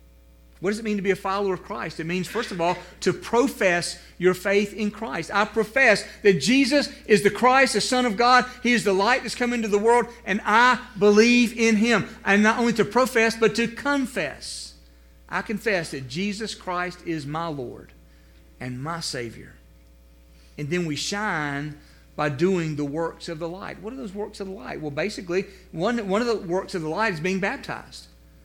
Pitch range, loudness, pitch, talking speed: 160-225 Hz, -23 LUFS, 195 Hz, 200 wpm